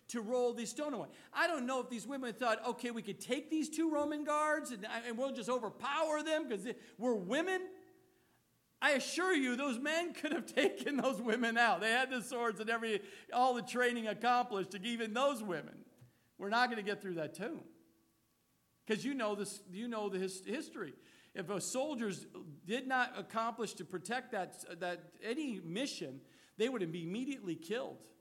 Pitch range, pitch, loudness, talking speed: 205-270 Hz, 240 Hz, -37 LUFS, 185 wpm